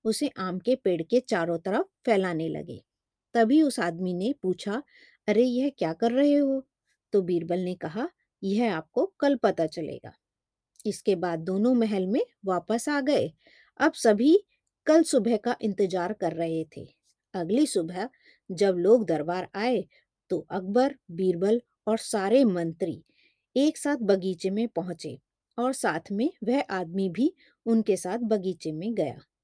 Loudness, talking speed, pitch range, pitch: -27 LUFS, 150 wpm, 180-255 Hz, 215 Hz